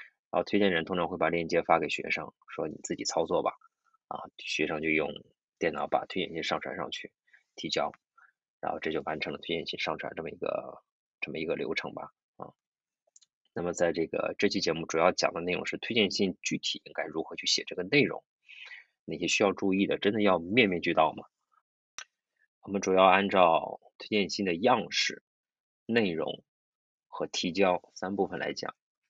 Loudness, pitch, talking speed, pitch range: -29 LUFS, 95 Hz, 270 characters per minute, 85-105 Hz